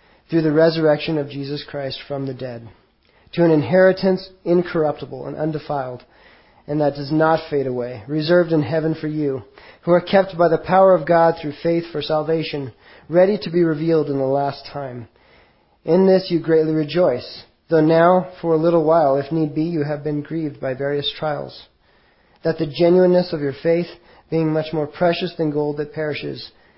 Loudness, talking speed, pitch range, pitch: -19 LUFS, 180 wpm, 145-170 Hz, 155 Hz